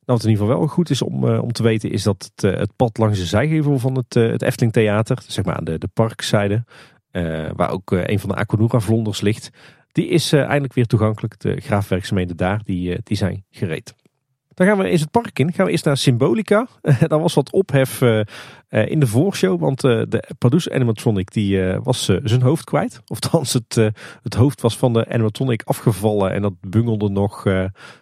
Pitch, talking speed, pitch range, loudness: 115 Hz, 225 wpm, 105-135 Hz, -19 LUFS